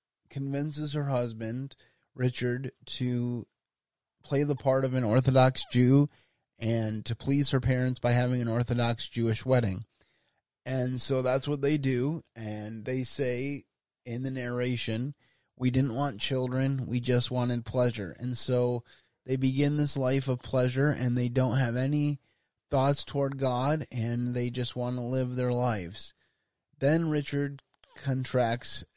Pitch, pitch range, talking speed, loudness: 130 Hz, 120-135 Hz, 145 wpm, -29 LUFS